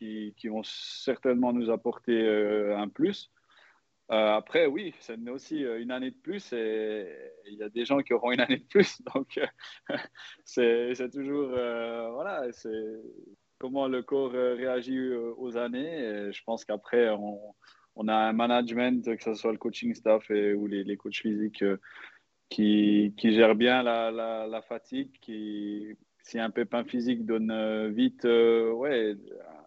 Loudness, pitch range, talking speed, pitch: -29 LUFS, 110-125 Hz, 155 wpm, 115 Hz